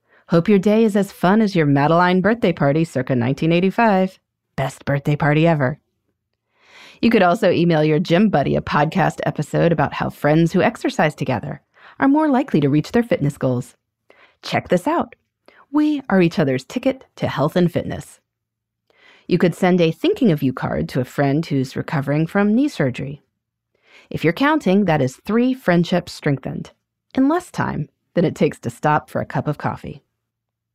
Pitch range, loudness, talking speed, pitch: 140-200 Hz, -18 LUFS, 175 wpm, 165 Hz